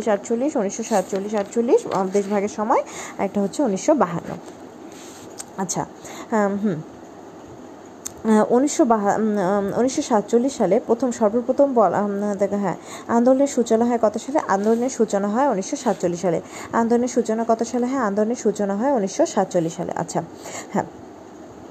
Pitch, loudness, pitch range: 220 Hz, -21 LUFS, 200-245 Hz